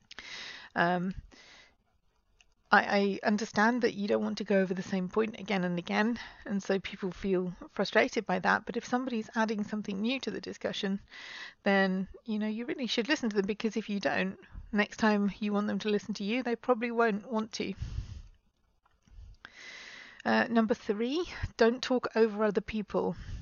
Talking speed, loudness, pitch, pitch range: 175 wpm, -31 LUFS, 215 Hz, 195-230 Hz